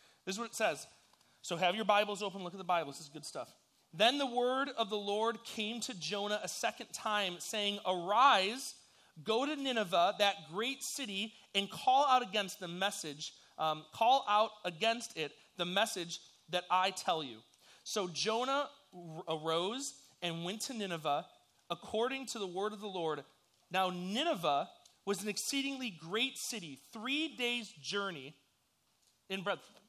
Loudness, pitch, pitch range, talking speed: -35 LUFS, 205 Hz, 175-230 Hz, 165 wpm